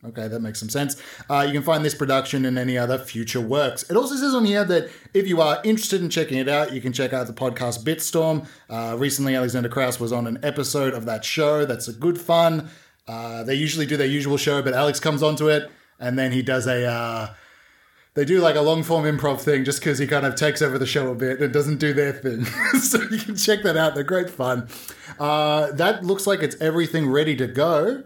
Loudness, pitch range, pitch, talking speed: -22 LUFS, 130-160 Hz, 145 Hz, 240 wpm